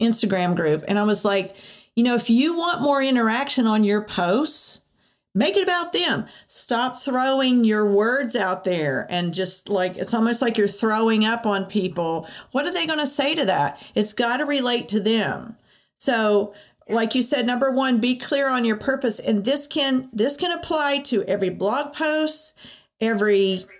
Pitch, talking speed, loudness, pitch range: 230 Hz, 185 wpm, -22 LUFS, 205-270 Hz